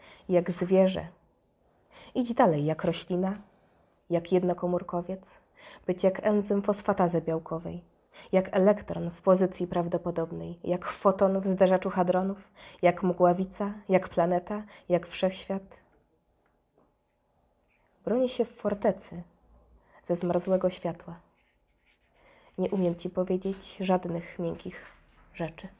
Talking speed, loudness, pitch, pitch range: 100 wpm, -28 LUFS, 185 Hz, 170-195 Hz